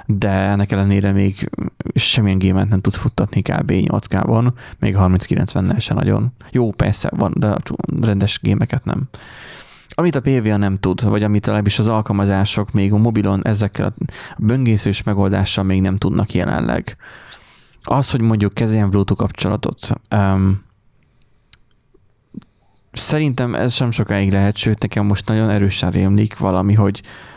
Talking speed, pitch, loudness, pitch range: 140 wpm, 105 Hz, -17 LUFS, 100-115 Hz